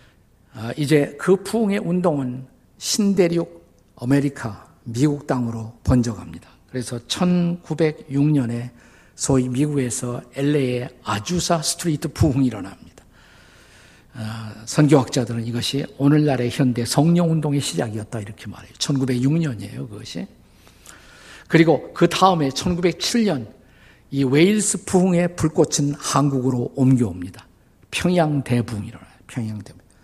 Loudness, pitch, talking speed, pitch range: -20 LUFS, 135 Hz, 275 characters per minute, 115-160 Hz